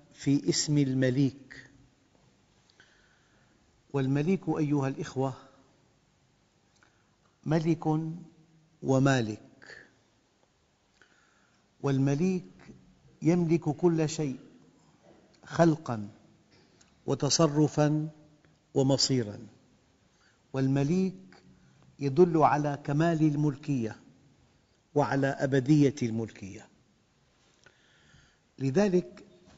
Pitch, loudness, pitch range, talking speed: 140 Hz, -28 LUFS, 135-160 Hz, 50 wpm